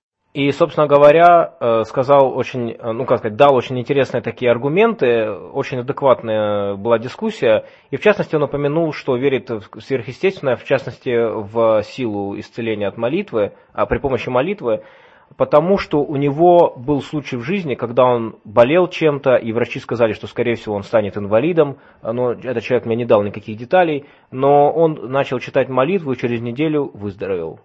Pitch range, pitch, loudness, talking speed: 115-155 Hz, 130 Hz, -17 LUFS, 165 wpm